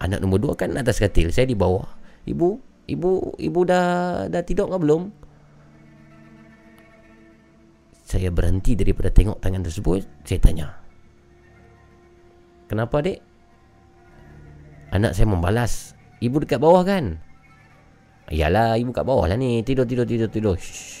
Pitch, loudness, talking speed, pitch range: 105 Hz, -22 LUFS, 130 wpm, 85-120 Hz